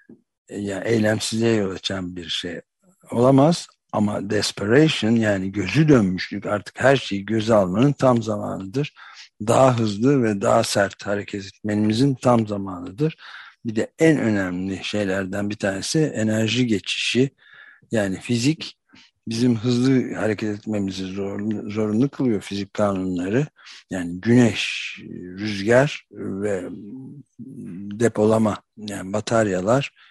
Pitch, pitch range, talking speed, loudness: 110 Hz, 100-125 Hz, 110 wpm, -21 LUFS